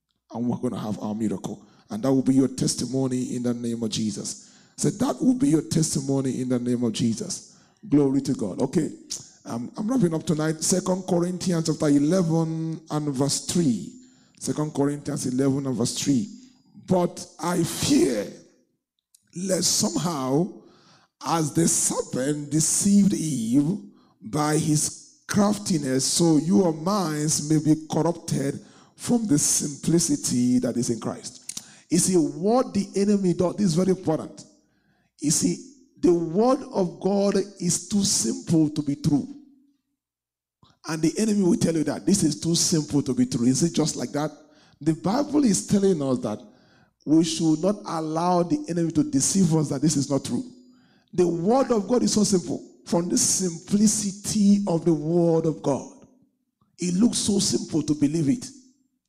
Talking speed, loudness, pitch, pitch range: 160 wpm, -23 LUFS, 165 Hz, 150-200 Hz